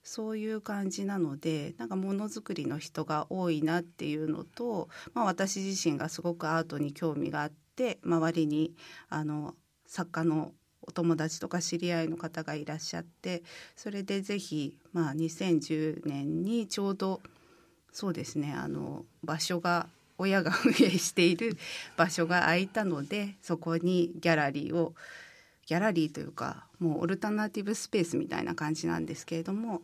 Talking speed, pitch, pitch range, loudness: 310 characters per minute, 170 Hz, 155-195 Hz, -32 LUFS